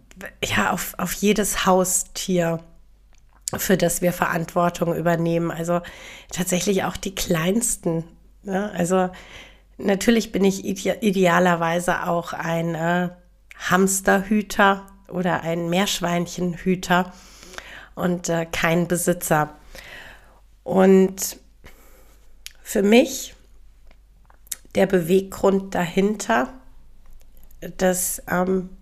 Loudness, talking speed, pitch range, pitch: -21 LUFS, 85 wpm, 170-195 Hz, 180 Hz